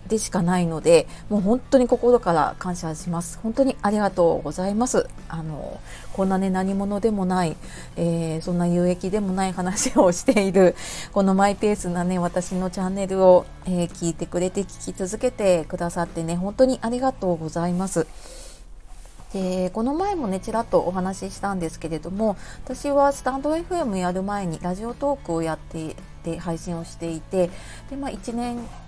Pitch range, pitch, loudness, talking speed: 170-220 Hz, 185 Hz, -23 LUFS, 350 characters per minute